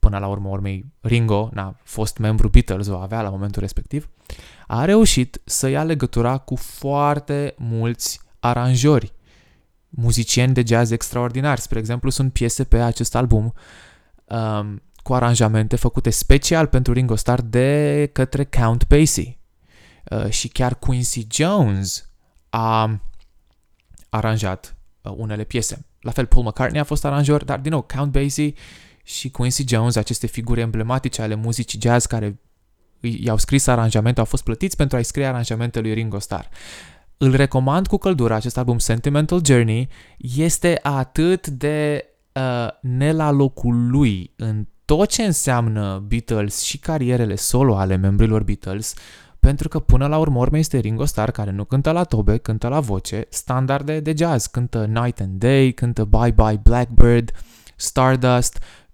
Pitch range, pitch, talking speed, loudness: 110-135 Hz, 120 Hz, 150 wpm, -20 LUFS